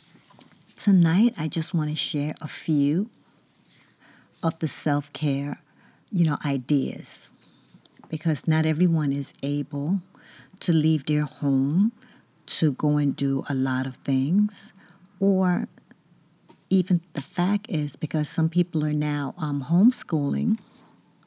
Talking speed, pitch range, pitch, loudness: 120 wpm, 145-185 Hz, 155 Hz, -24 LUFS